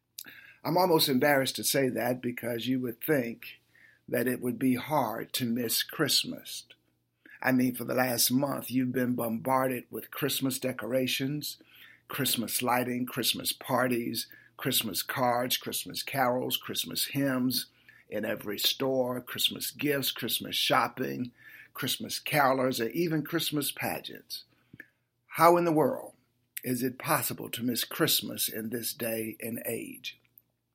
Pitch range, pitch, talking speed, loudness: 120-135 Hz, 125 Hz, 135 wpm, -29 LUFS